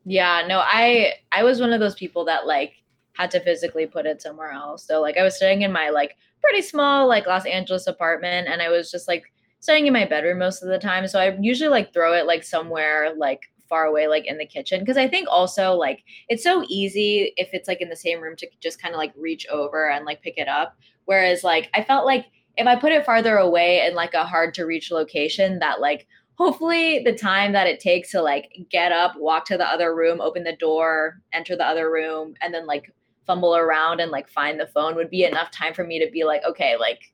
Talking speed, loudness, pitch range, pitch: 240 wpm, -21 LUFS, 160-195 Hz, 175 Hz